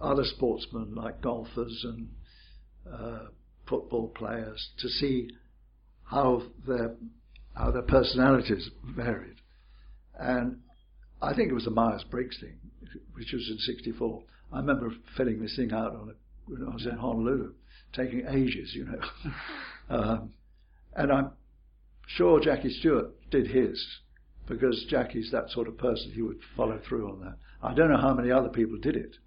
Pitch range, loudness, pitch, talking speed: 105-125 Hz, -30 LUFS, 115 Hz, 150 wpm